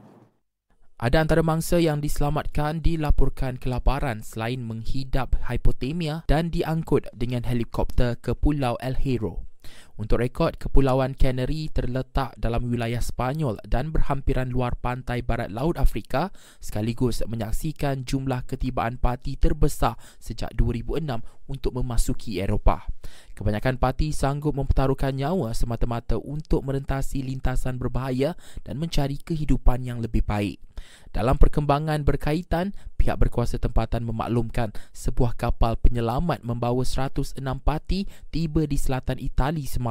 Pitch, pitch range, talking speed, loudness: 130 Hz, 115-140 Hz, 115 wpm, -27 LUFS